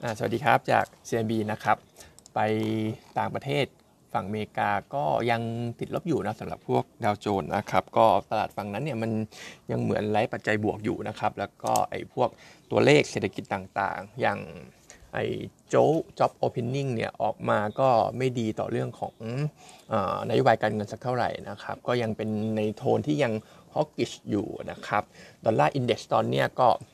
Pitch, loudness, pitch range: 110 Hz, -27 LUFS, 105-120 Hz